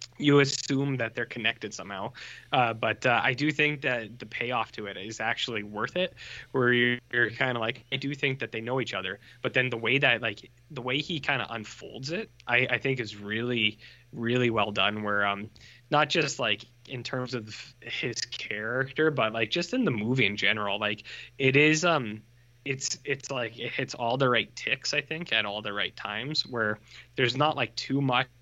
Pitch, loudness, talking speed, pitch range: 120 Hz, -28 LUFS, 210 wpm, 110-135 Hz